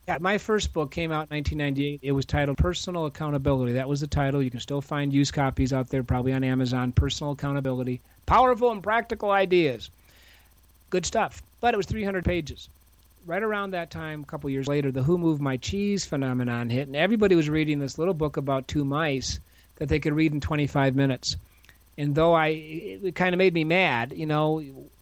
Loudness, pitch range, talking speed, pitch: -26 LUFS, 130-165 Hz, 200 wpm, 145 Hz